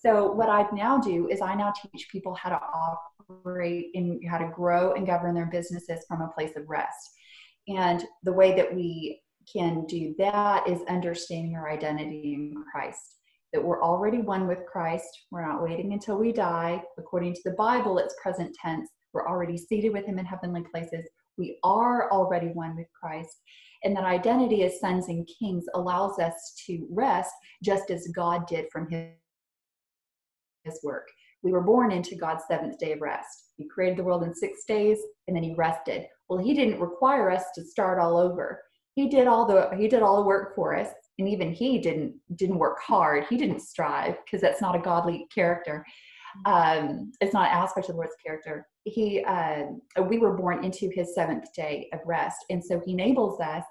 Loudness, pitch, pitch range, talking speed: -27 LUFS, 180 Hz, 170-200 Hz, 195 wpm